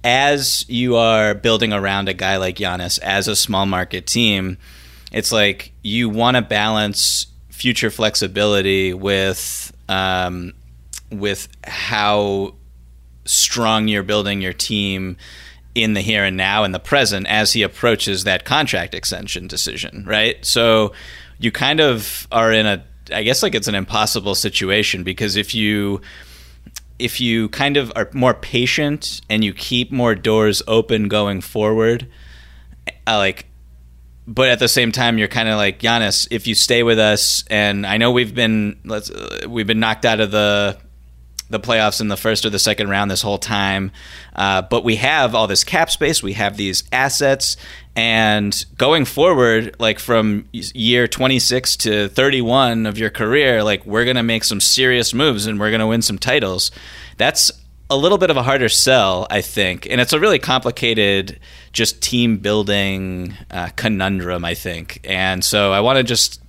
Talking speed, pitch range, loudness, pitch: 170 wpm, 95-115 Hz, -16 LUFS, 105 Hz